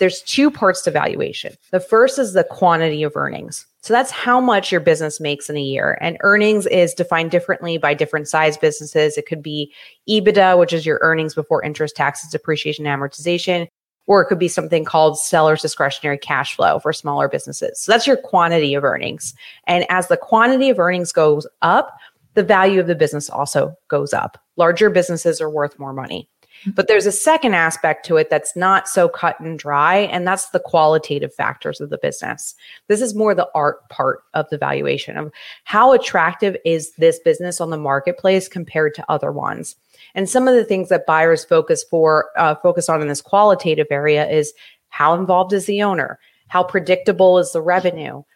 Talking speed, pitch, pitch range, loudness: 195 wpm, 175 Hz, 155-195 Hz, -17 LUFS